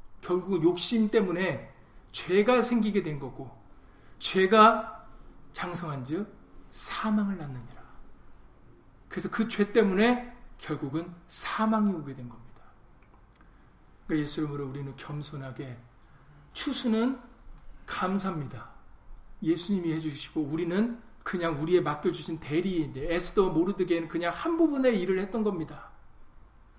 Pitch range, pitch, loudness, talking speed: 145-205 Hz, 170 Hz, -28 LUFS, 255 characters per minute